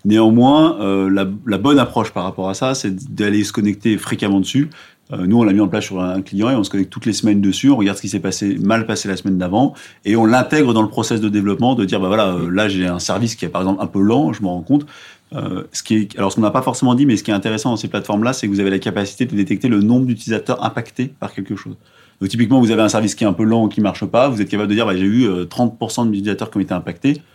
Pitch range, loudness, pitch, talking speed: 100-115 Hz, -17 LUFS, 105 Hz, 305 wpm